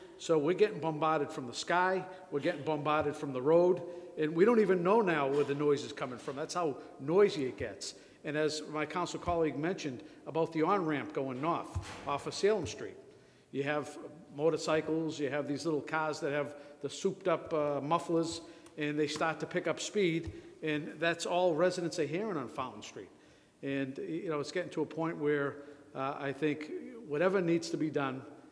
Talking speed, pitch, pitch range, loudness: 195 wpm, 155 Hz, 145-170 Hz, -33 LUFS